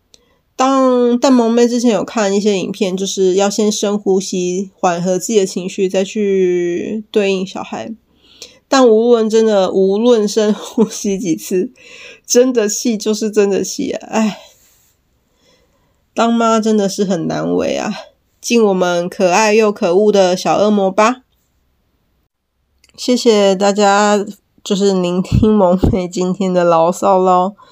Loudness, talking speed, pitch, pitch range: -14 LUFS, 200 characters per minute, 205 Hz, 190-225 Hz